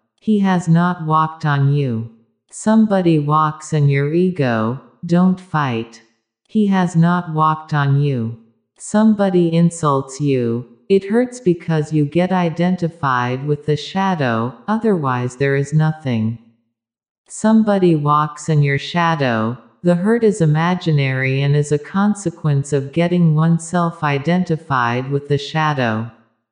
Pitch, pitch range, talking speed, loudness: 155 Hz, 130-175 Hz, 125 wpm, -17 LUFS